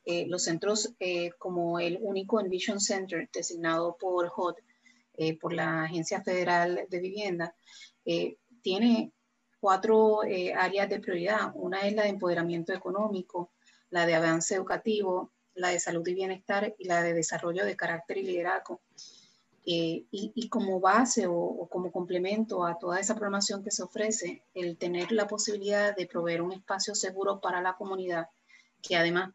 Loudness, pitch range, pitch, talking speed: -30 LUFS, 175-205 Hz, 185 Hz, 160 wpm